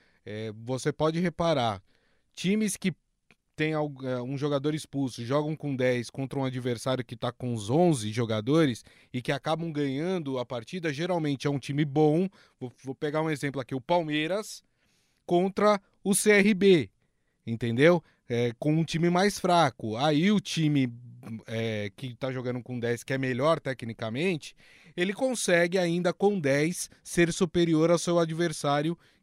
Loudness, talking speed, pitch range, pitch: -28 LUFS, 145 wpm, 125-175 Hz, 150 Hz